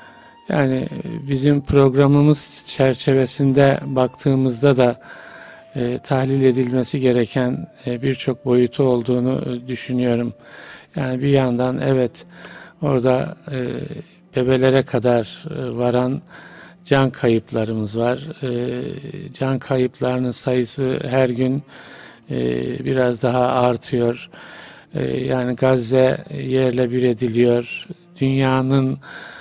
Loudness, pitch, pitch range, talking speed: -19 LUFS, 130 Hz, 125-140 Hz, 90 wpm